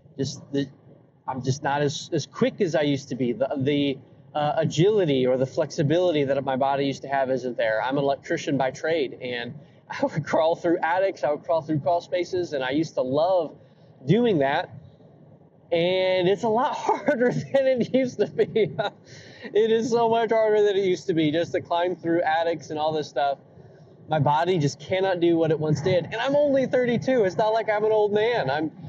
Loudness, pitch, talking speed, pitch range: -24 LUFS, 160 Hz, 210 wpm, 140-195 Hz